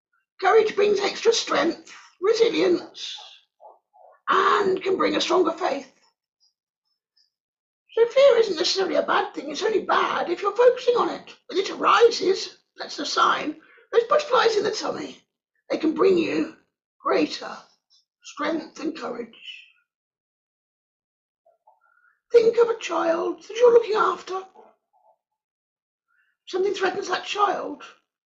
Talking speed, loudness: 120 wpm, -22 LUFS